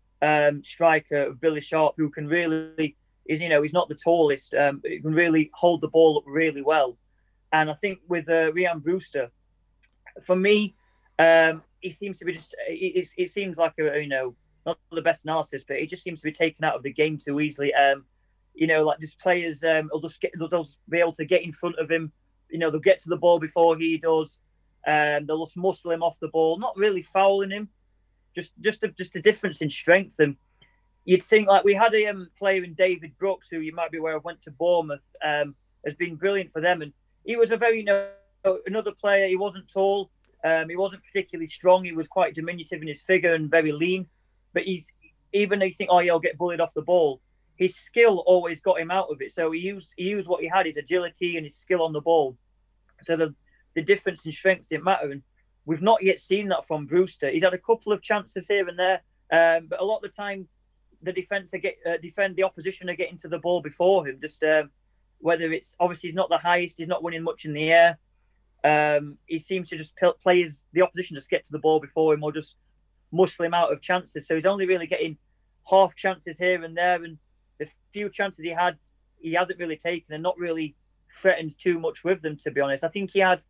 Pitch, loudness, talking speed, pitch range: 170 Hz, -24 LUFS, 230 wpm, 155-185 Hz